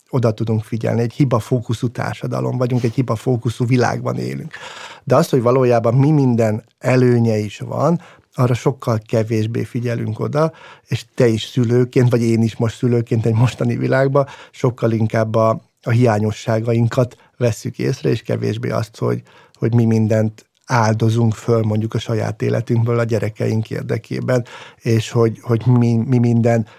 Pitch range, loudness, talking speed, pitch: 115-125 Hz, -18 LUFS, 150 wpm, 120 Hz